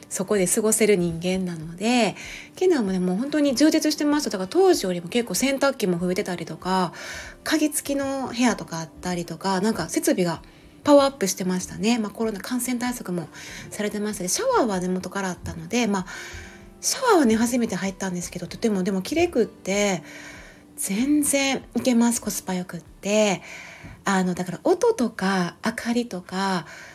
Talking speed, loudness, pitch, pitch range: 385 characters per minute, -23 LUFS, 200 Hz, 180-250 Hz